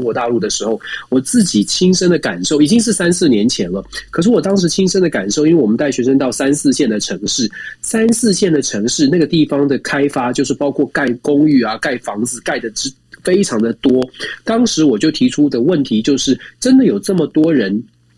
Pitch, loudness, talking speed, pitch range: 150 Hz, -14 LUFS, 315 characters per minute, 135-195 Hz